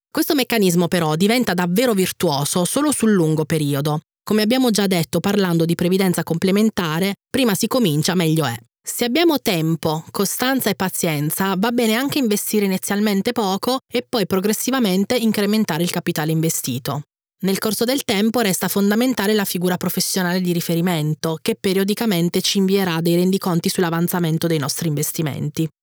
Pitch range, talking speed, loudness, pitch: 170-220 Hz, 145 wpm, -19 LUFS, 190 Hz